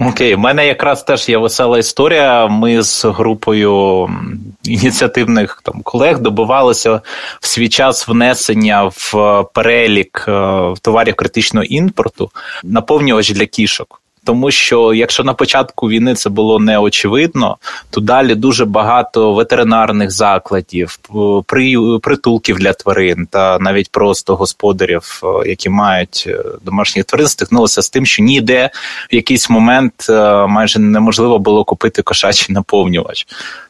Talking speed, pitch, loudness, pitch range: 120 wpm, 110 Hz, -11 LUFS, 100-120 Hz